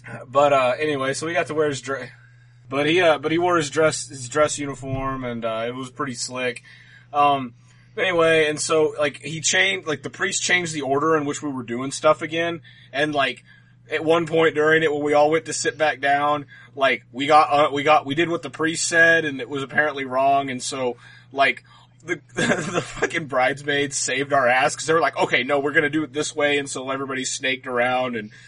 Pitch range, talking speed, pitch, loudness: 130-155 Hz, 230 wpm, 145 Hz, -21 LUFS